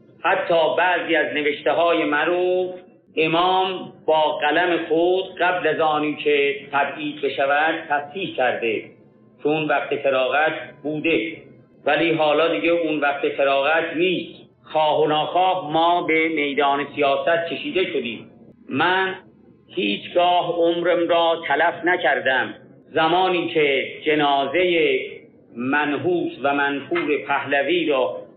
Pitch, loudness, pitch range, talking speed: 165 Hz, -20 LUFS, 150-180 Hz, 110 wpm